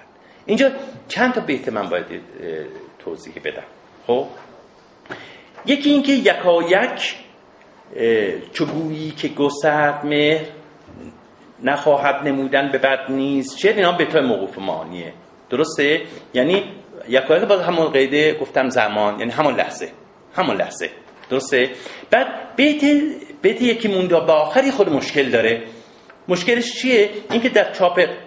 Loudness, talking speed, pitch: -18 LUFS, 125 wpm, 175 Hz